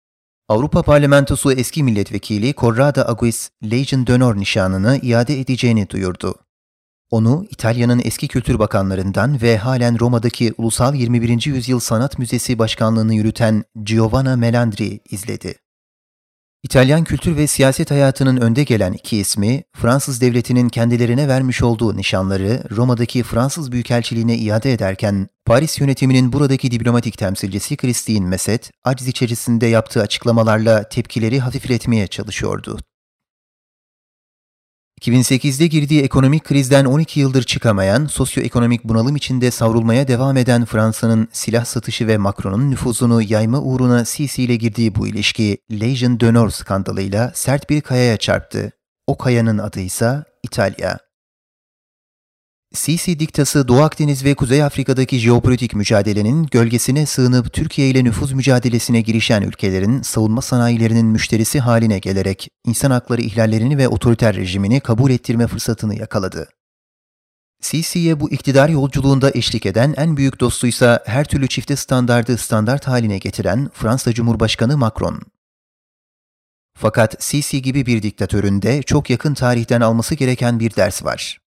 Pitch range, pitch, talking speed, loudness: 110-135 Hz, 120 Hz, 120 wpm, -16 LUFS